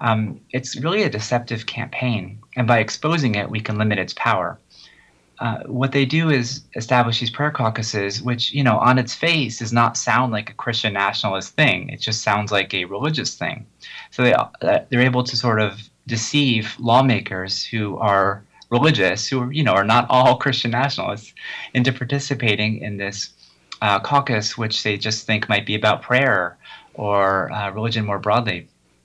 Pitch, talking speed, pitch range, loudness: 115 Hz, 180 wpm, 105-125 Hz, -20 LUFS